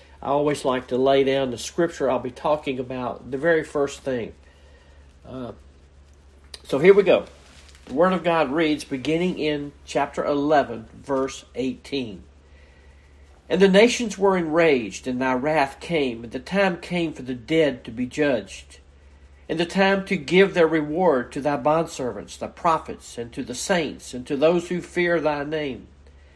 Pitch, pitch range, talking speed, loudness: 140 Hz, 115-165 Hz, 170 wpm, -22 LUFS